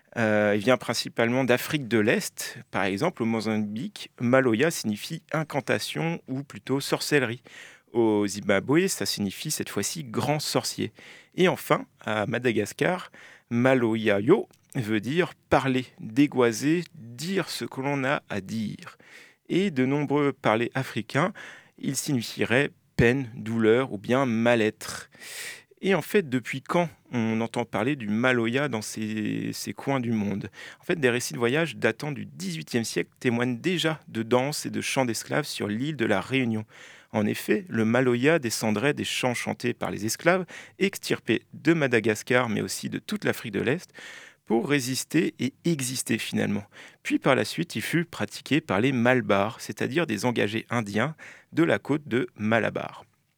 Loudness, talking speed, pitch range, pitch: -26 LUFS, 155 wpm, 110-145 Hz, 125 Hz